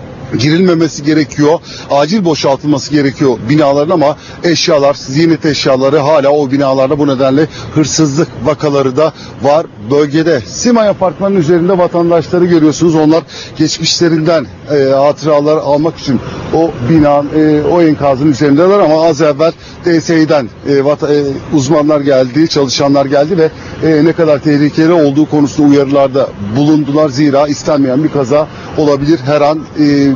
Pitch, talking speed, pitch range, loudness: 150 Hz, 130 wpm, 140-160 Hz, -10 LUFS